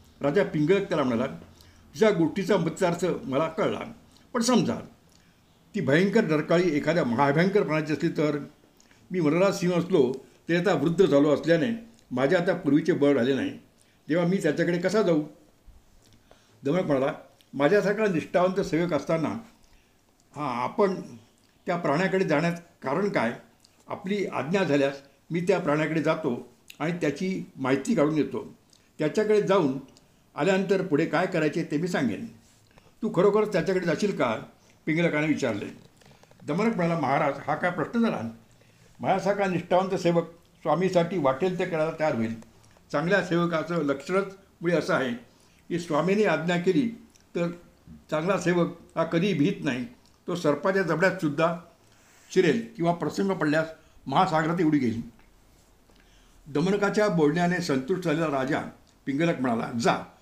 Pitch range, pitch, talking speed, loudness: 145-190 Hz, 165 Hz, 130 wpm, -26 LUFS